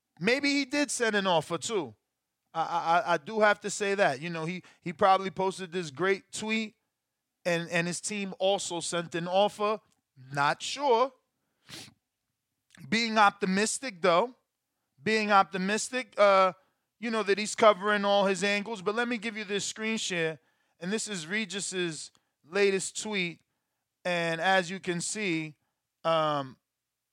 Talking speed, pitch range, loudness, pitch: 150 wpm, 170-215 Hz, -28 LUFS, 195 Hz